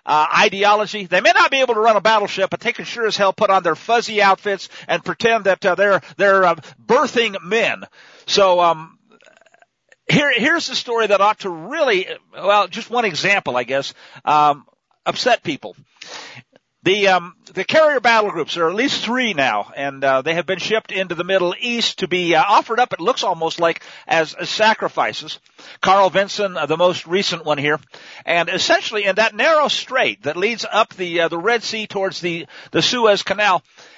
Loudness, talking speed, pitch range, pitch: -17 LUFS, 195 wpm, 175-225 Hz, 195 Hz